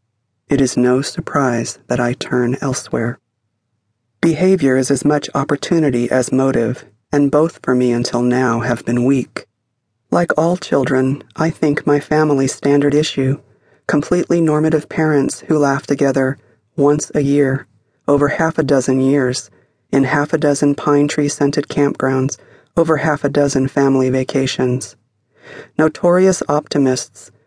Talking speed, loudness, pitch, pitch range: 140 wpm, -16 LUFS, 140 Hz, 125-145 Hz